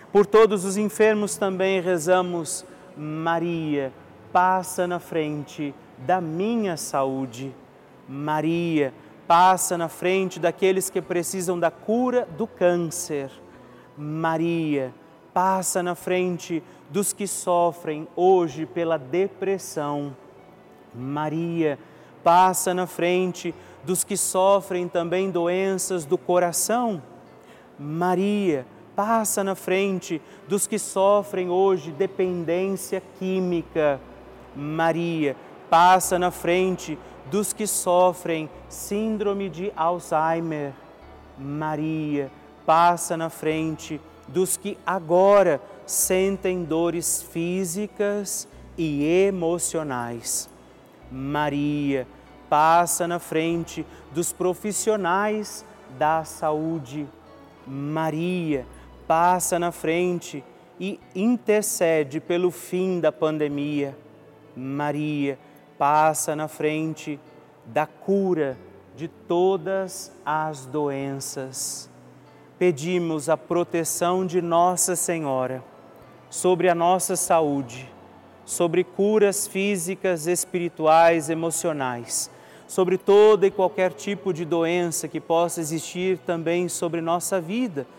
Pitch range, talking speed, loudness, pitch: 150-185 Hz, 90 wpm, -23 LUFS, 170 Hz